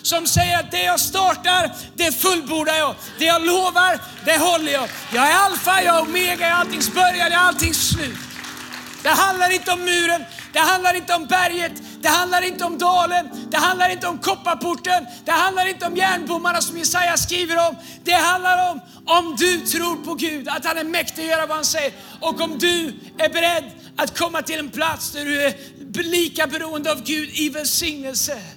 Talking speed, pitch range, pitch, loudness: 195 wpm, 315-360 Hz, 335 Hz, -19 LUFS